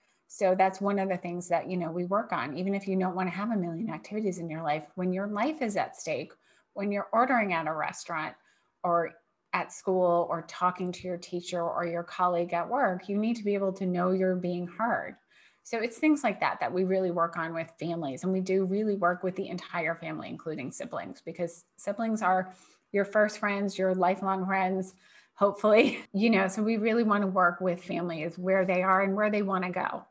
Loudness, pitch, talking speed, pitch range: -29 LUFS, 185 Hz, 225 wpm, 175-200 Hz